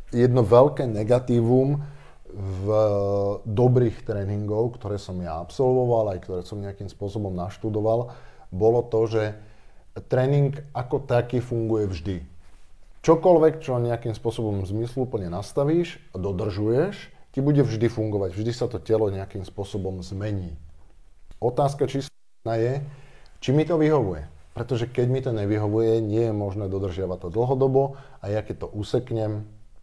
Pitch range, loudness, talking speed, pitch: 100-125 Hz, -24 LUFS, 135 wpm, 110 Hz